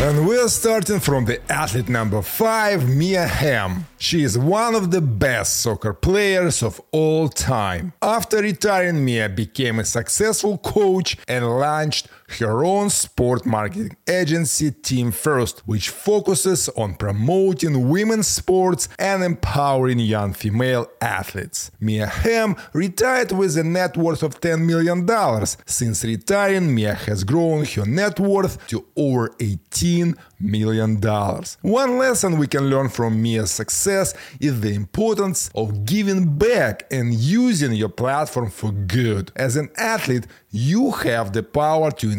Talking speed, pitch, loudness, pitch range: 140 wpm, 145 Hz, -20 LUFS, 110-185 Hz